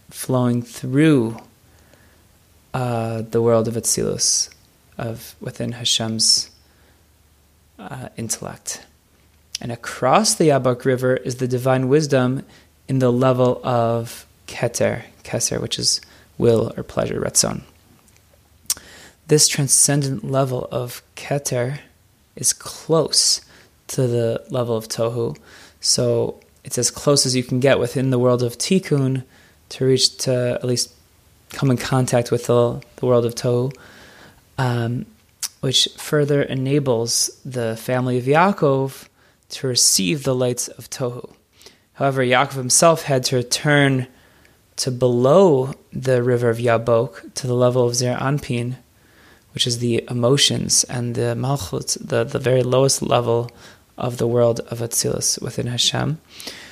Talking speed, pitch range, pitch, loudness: 130 wpm, 115-130 Hz, 125 Hz, -19 LUFS